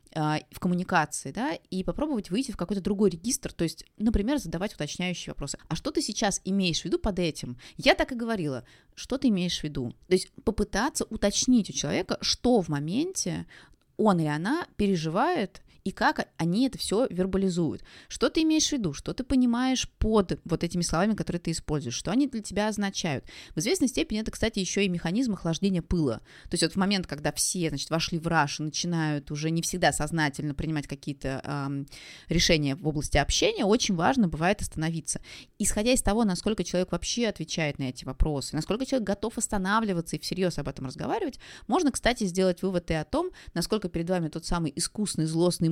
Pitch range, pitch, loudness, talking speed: 160-220 Hz, 180 Hz, -28 LUFS, 190 wpm